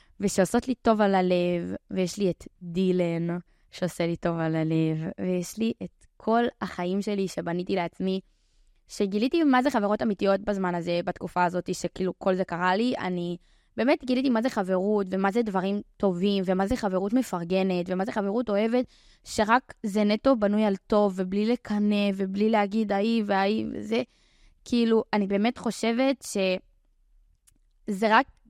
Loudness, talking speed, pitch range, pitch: -26 LUFS, 155 wpm, 180-220 Hz, 200 Hz